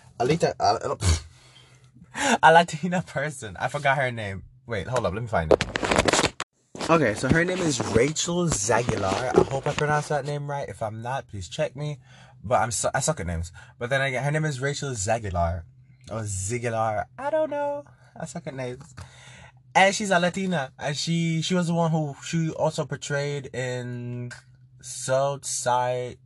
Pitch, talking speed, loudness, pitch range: 130 Hz, 175 wpm, -25 LUFS, 120-155 Hz